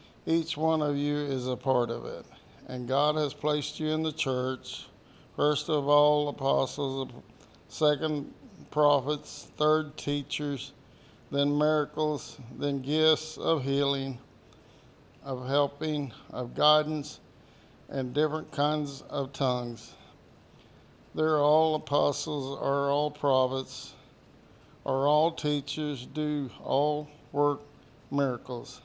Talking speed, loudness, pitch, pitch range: 110 wpm, -29 LUFS, 145 Hz, 135-150 Hz